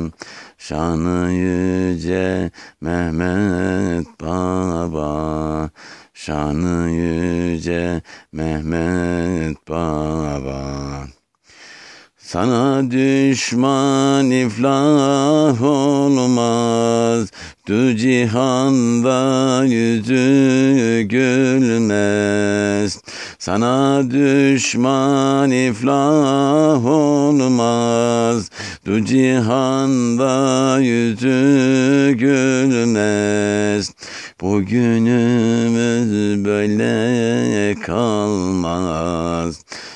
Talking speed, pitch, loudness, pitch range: 40 wpm, 115 Hz, -16 LUFS, 90-130 Hz